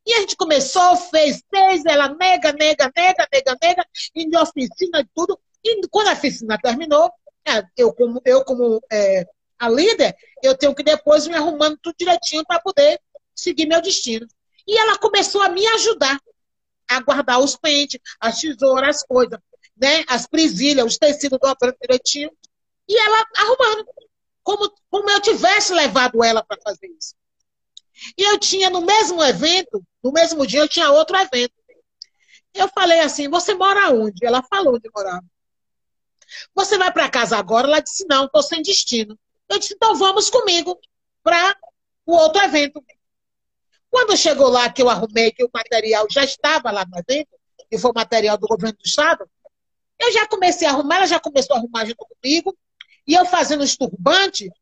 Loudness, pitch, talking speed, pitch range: -17 LUFS, 305 Hz, 170 wpm, 255-375 Hz